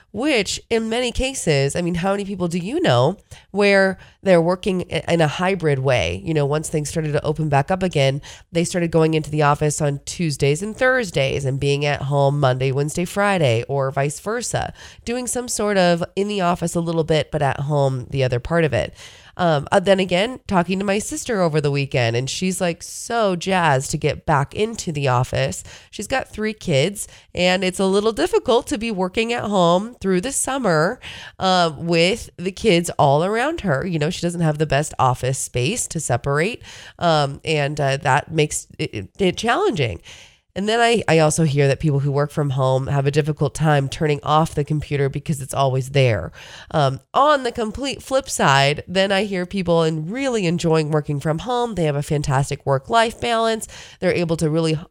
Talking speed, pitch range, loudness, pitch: 200 wpm, 140-195 Hz, -20 LUFS, 160 Hz